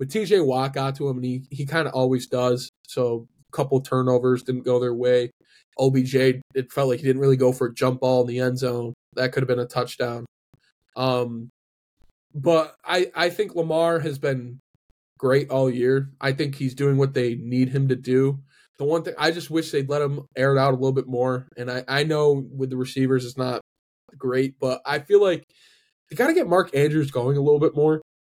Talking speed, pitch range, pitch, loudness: 225 wpm, 125-145 Hz, 130 Hz, -23 LUFS